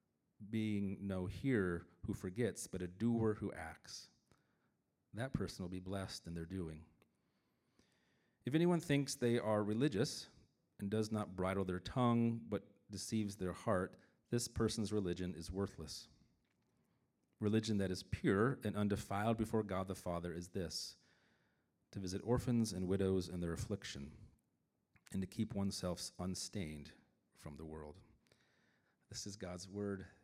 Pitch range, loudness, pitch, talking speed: 90-110 Hz, -41 LUFS, 100 Hz, 140 wpm